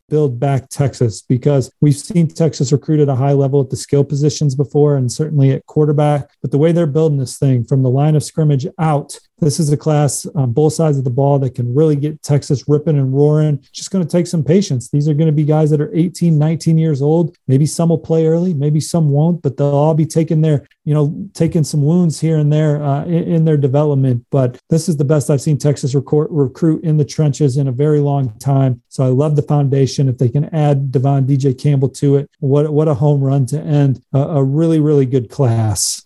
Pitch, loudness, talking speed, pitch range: 145 Hz, -15 LUFS, 240 wpm, 140-155 Hz